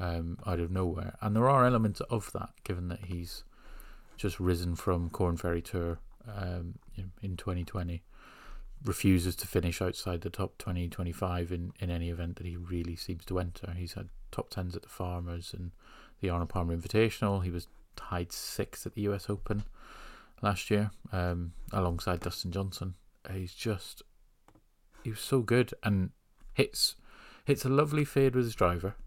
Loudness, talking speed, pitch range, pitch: -33 LUFS, 180 wpm, 85-105 Hz, 90 Hz